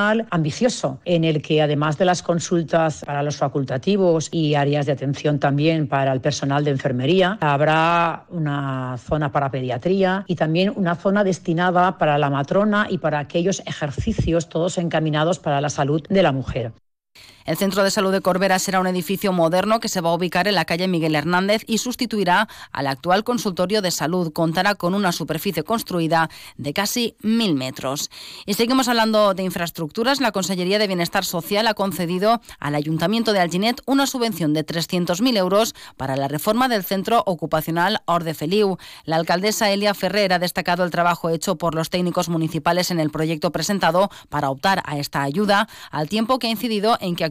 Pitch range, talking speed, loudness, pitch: 155-200 Hz, 180 wpm, -20 LUFS, 175 Hz